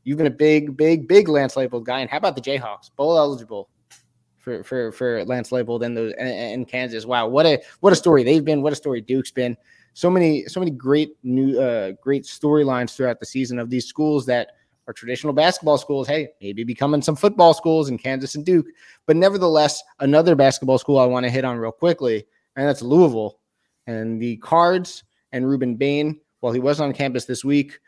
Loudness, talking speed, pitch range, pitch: -20 LUFS, 205 wpm, 125-155 Hz, 140 Hz